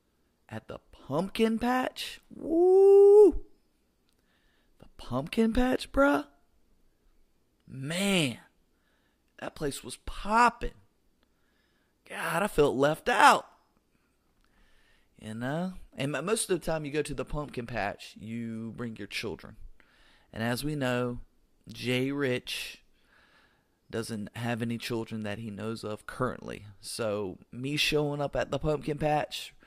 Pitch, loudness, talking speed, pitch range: 140 Hz, -28 LUFS, 120 wpm, 115-190 Hz